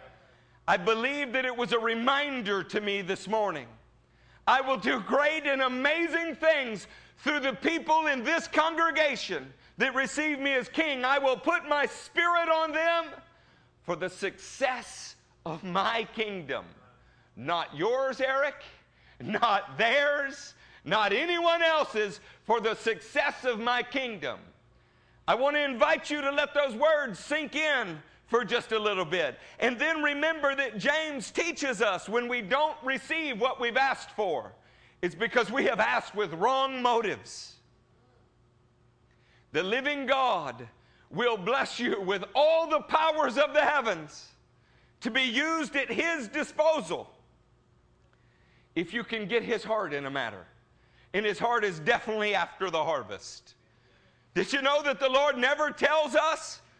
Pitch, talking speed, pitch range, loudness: 270 Hz, 150 wpm, 225-295 Hz, -28 LUFS